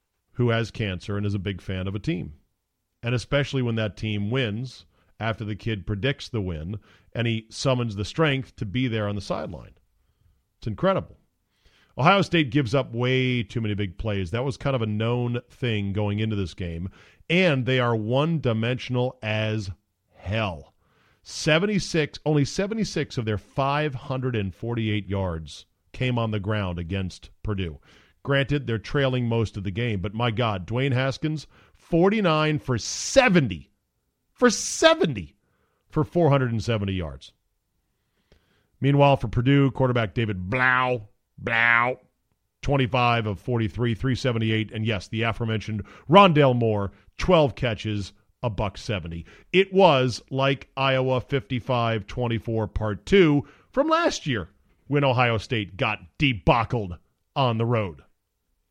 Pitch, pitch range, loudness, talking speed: 115 Hz, 100-135 Hz, -24 LUFS, 145 wpm